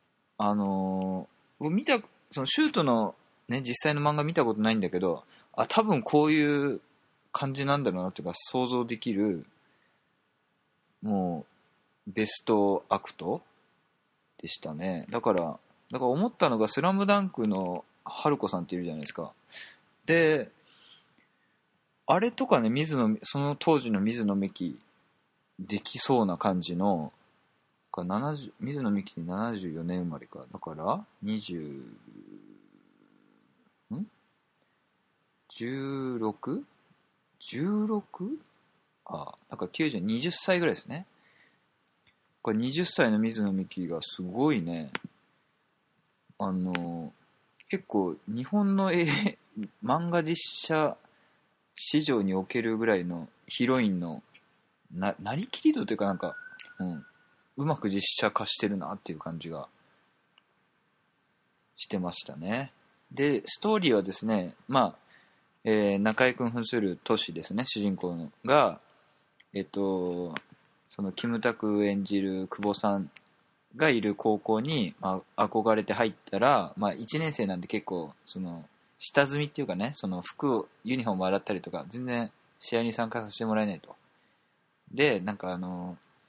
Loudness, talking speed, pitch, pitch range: -30 LUFS, 240 characters per minute, 115 Hz, 95-155 Hz